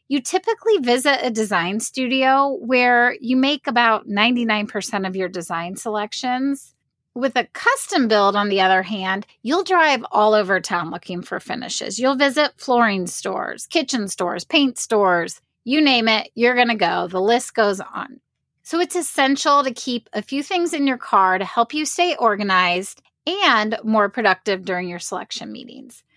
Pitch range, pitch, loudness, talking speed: 200-275 Hz, 235 Hz, -19 LUFS, 165 wpm